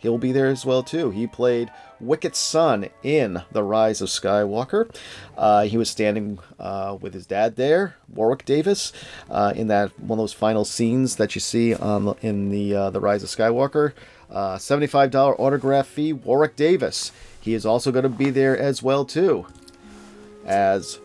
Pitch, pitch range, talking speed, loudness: 110 Hz, 100-135 Hz, 180 wpm, -21 LUFS